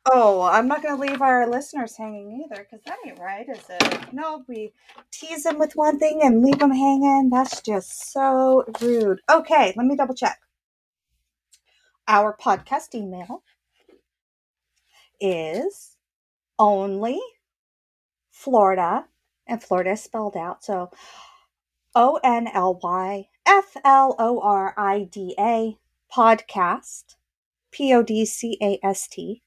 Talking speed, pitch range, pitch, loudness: 135 wpm, 205-280 Hz, 240 Hz, -21 LUFS